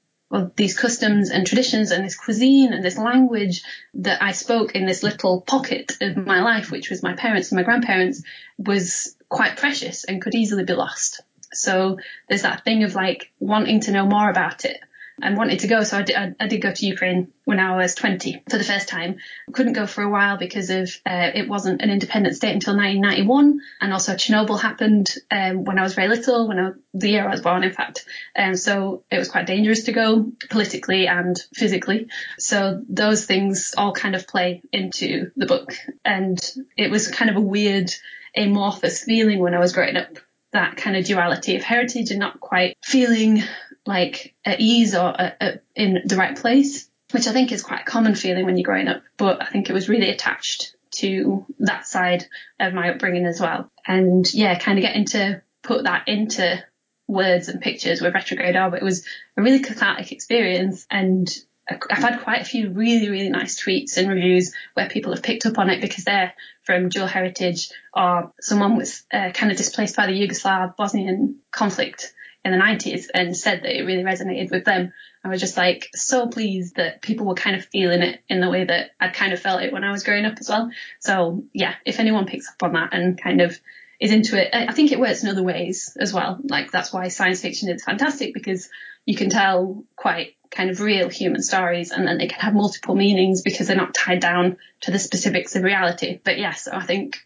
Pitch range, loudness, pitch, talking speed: 185-225 Hz, -20 LUFS, 200 Hz, 215 wpm